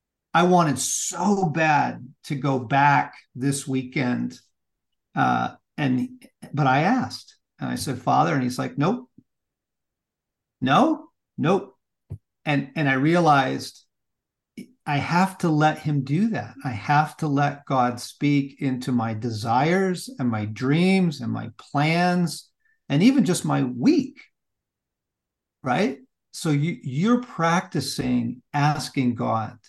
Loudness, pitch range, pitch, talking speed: -23 LUFS, 130-180 Hz, 150 Hz, 125 wpm